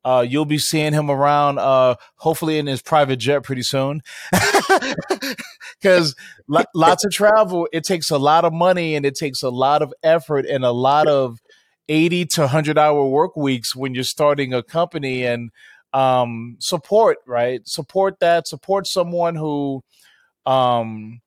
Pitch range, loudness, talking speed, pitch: 130-170 Hz, -18 LUFS, 160 wpm, 150 Hz